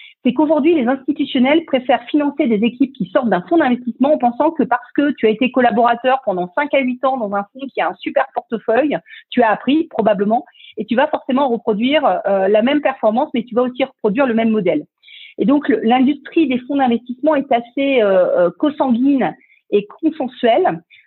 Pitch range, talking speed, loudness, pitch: 230-290 Hz, 195 wpm, -16 LUFS, 260 Hz